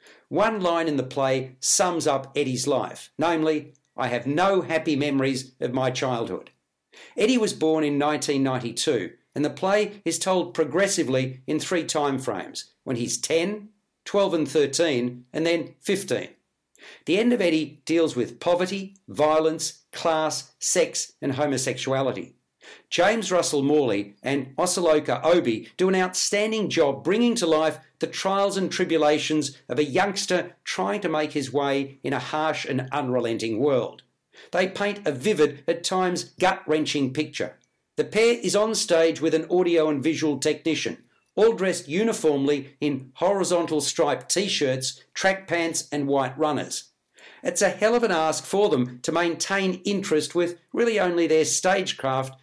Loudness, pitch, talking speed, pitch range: -24 LUFS, 155 Hz, 150 wpm, 145-185 Hz